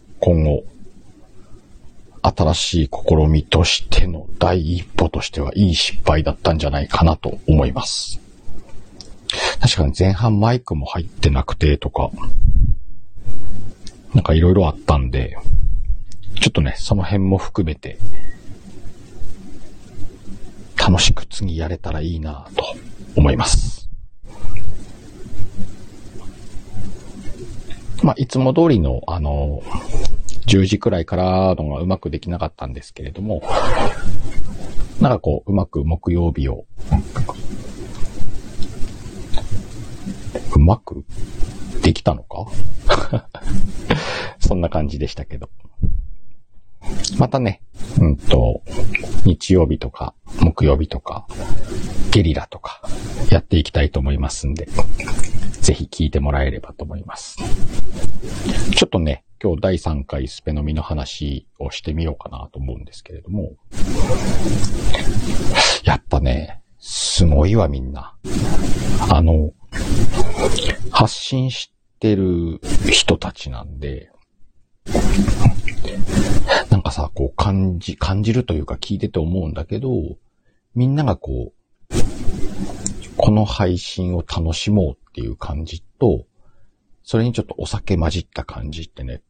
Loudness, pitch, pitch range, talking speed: -20 LUFS, 95 Hz, 80-105 Hz, 220 characters per minute